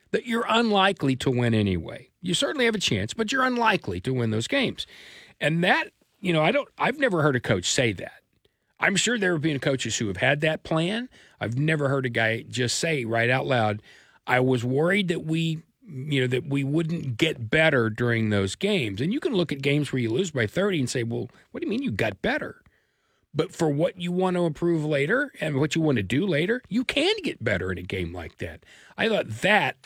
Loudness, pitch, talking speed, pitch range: -24 LUFS, 150 Hz, 230 wpm, 120-180 Hz